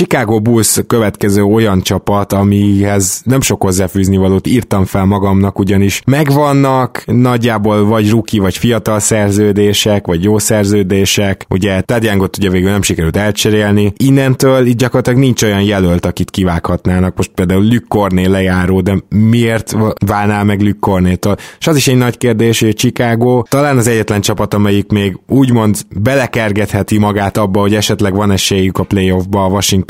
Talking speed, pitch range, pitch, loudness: 150 wpm, 95-115 Hz, 105 Hz, -11 LUFS